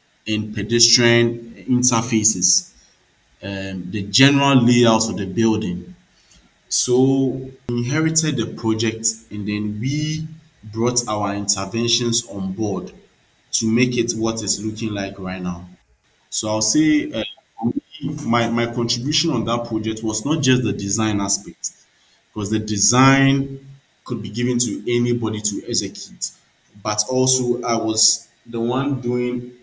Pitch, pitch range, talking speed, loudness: 115 Hz, 105-125 Hz, 130 wpm, -19 LUFS